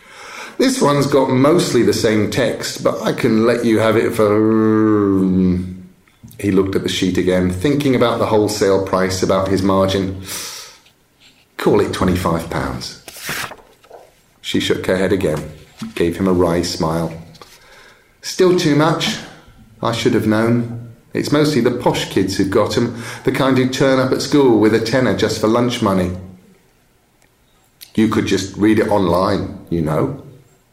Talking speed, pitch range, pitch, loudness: 155 wpm, 95-130 Hz, 110 Hz, -16 LUFS